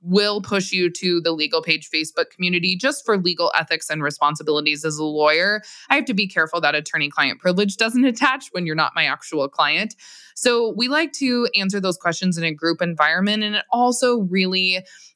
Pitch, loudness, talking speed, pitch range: 180 Hz, -20 LUFS, 200 wpm, 160-210 Hz